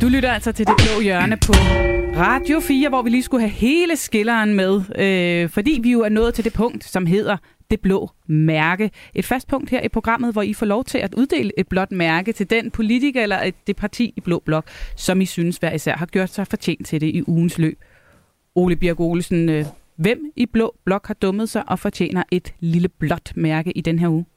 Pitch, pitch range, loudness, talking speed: 195 Hz, 170-230 Hz, -19 LUFS, 225 wpm